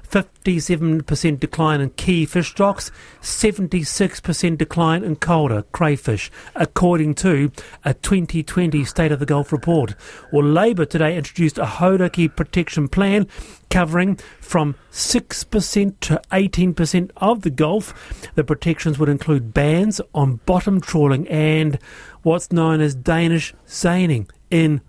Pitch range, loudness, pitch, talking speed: 150-180 Hz, -19 LUFS, 165 Hz, 125 wpm